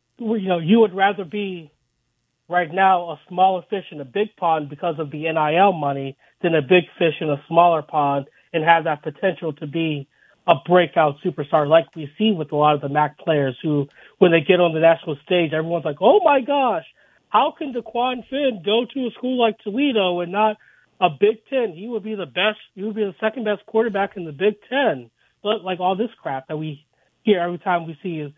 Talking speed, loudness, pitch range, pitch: 220 wpm, -20 LUFS, 155-210 Hz, 180 Hz